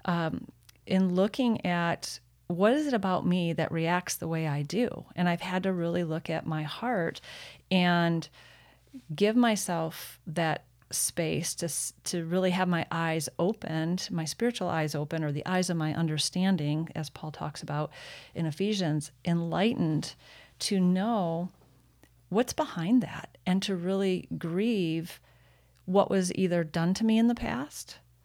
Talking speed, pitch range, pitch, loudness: 150 wpm, 155-185 Hz, 170 Hz, -29 LUFS